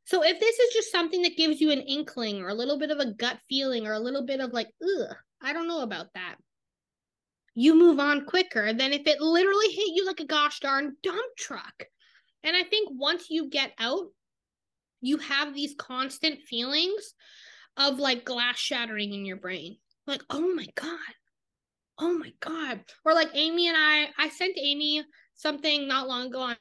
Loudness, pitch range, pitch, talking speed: -26 LUFS, 260-335 Hz, 295 Hz, 195 wpm